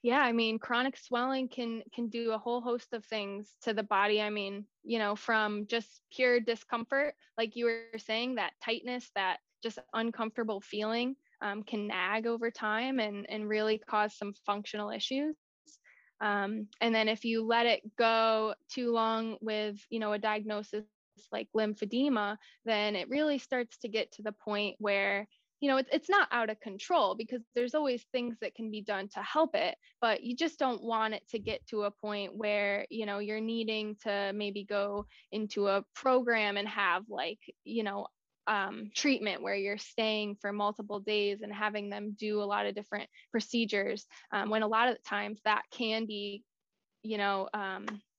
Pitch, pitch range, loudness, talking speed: 220 Hz, 210-235 Hz, -33 LUFS, 185 wpm